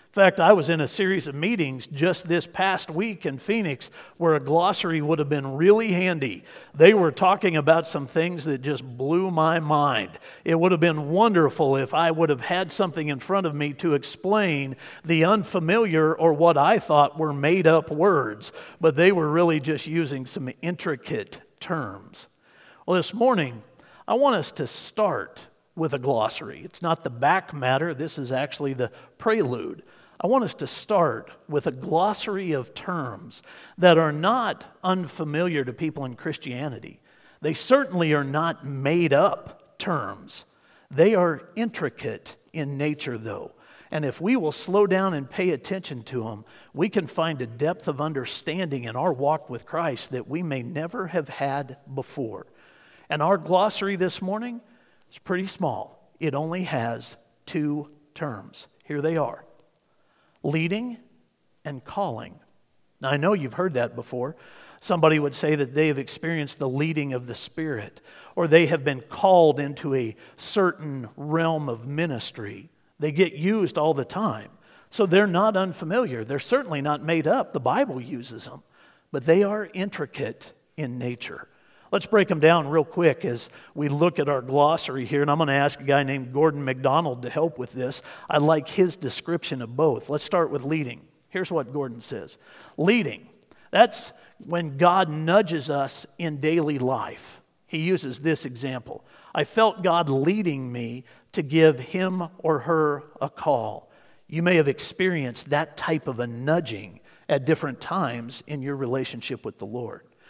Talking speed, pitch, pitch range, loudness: 170 wpm, 155 Hz, 140-180 Hz, -24 LUFS